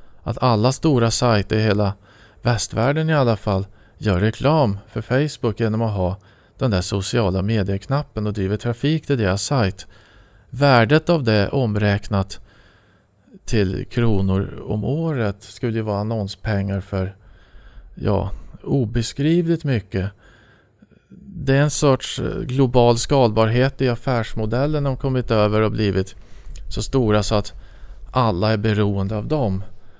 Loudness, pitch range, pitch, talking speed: -20 LUFS, 100-130 Hz, 110 Hz, 130 wpm